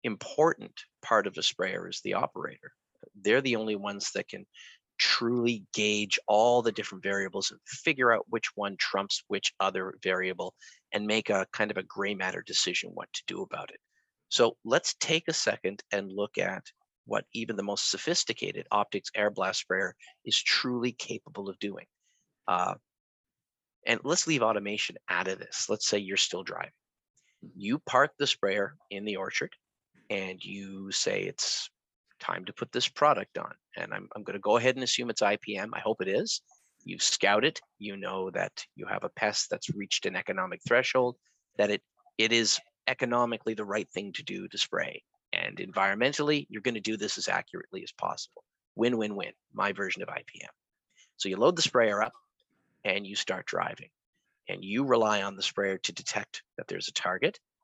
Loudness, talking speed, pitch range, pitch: -30 LUFS, 180 wpm, 100-120 Hz, 110 Hz